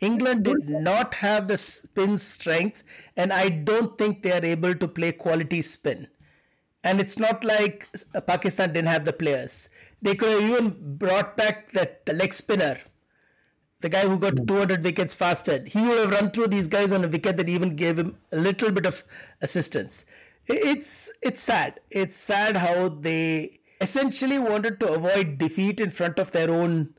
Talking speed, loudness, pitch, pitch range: 175 wpm, -24 LUFS, 195 Hz, 175-210 Hz